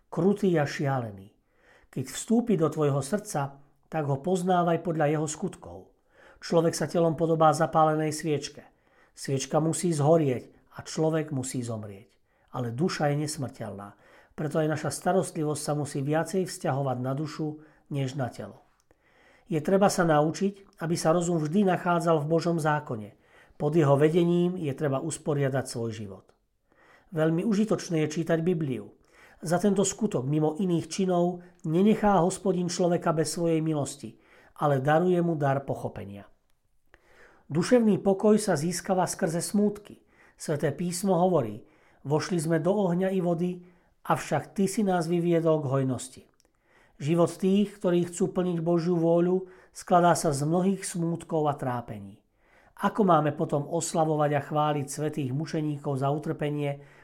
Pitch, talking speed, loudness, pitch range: 160 Hz, 140 wpm, -27 LUFS, 145-180 Hz